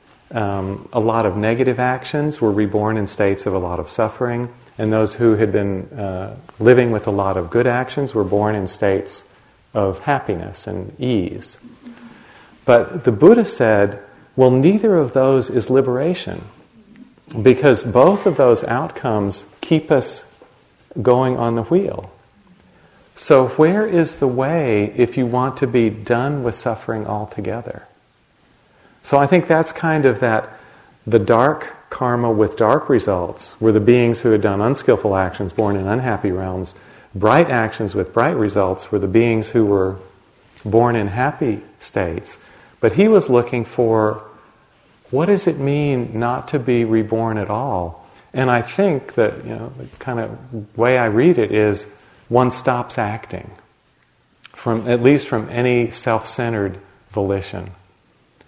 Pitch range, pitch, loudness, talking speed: 105-130 Hz, 115 Hz, -17 LUFS, 155 wpm